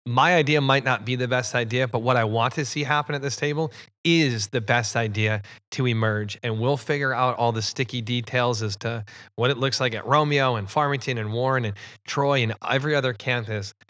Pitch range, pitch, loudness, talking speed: 115-140 Hz, 125 Hz, -23 LUFS, 215 wpm